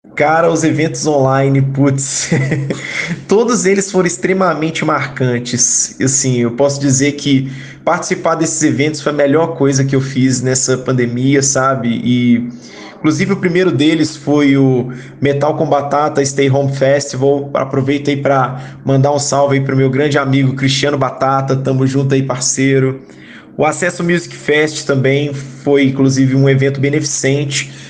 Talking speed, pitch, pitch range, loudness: 145 wpm, 140 Hz, 135-150 Hz, -13 LUFS